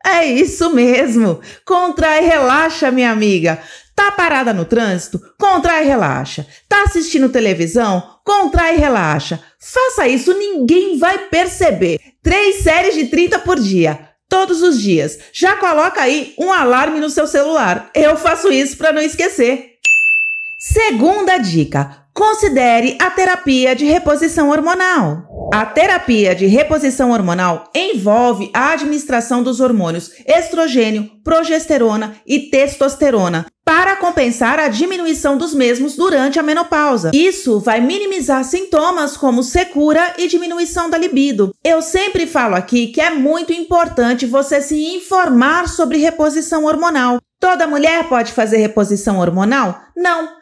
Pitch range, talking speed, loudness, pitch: 240-345 Hz, 130 wpm, -13 LUFS, 300 Hz